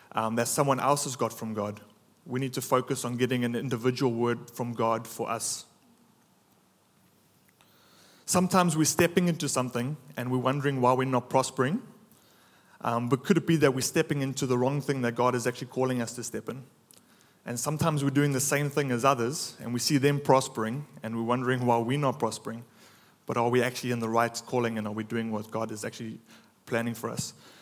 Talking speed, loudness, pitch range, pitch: 205 wpm, -28 LUFS, 115-140 Hz, 125 Hz